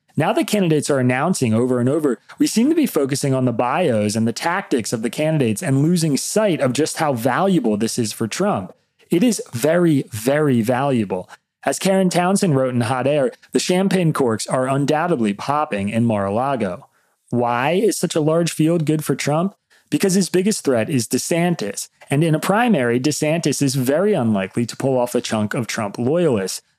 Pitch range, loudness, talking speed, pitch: 120-170 Hz, -19 LUFS, 195 wpm, 140 Hz